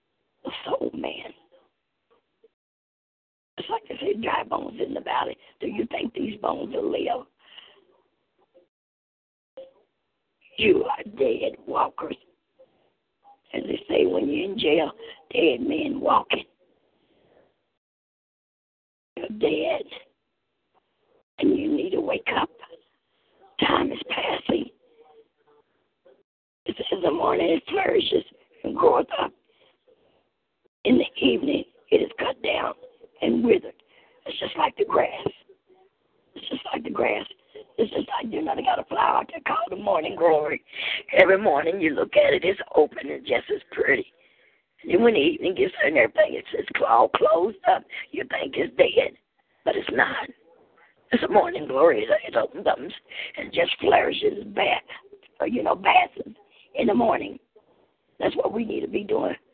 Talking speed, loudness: 140 wpm, -24 LUFS